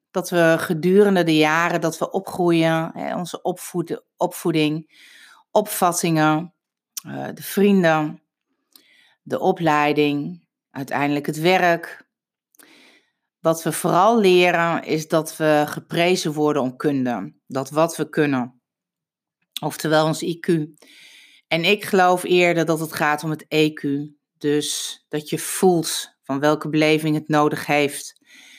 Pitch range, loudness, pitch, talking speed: 150-180 Hz, -20 LUFS, 160 Hz, 120 wpm